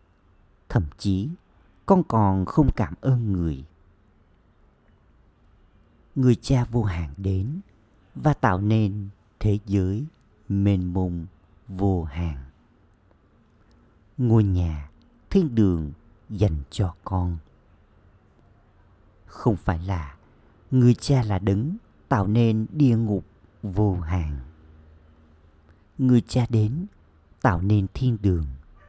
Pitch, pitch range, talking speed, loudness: 100 Hz, 85-110 Hz, 100 wpm, -24 LUFS